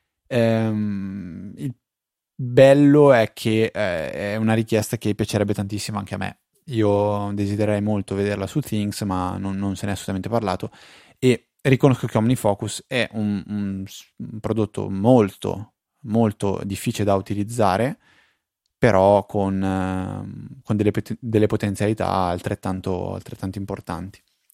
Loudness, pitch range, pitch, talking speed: -21 LUFS, 100-115 Hz, 105 Hz, 130 wpm